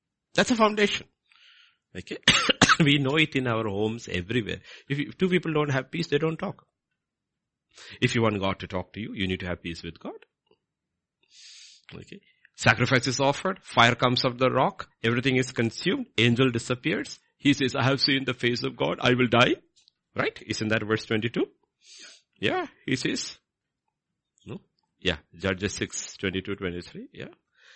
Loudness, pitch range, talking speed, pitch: -25 LUFS, 110-140 Hz, 170 wpm, 125 Hz